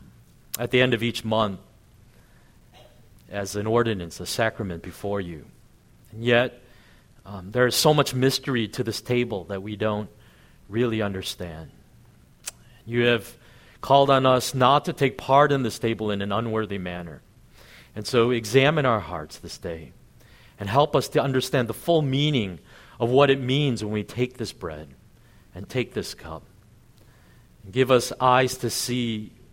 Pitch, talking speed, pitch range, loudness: 120 Hz, 160 wpm, 100-125 Hz, -23 LUFS